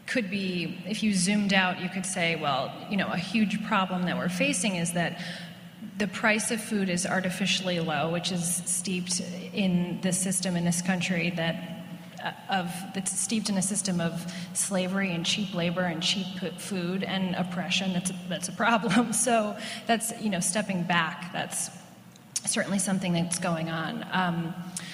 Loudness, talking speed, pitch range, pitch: -28 LUFS, 175 wpm, 175-195 Hz, 185 Hz